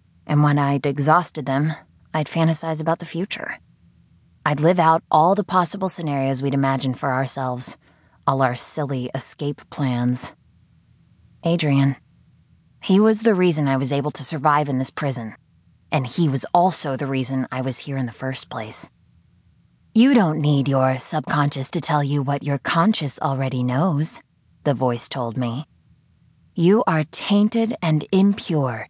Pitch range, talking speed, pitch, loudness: 130-165 Hz, 155 wpm, 145 Hz, -21 LUFS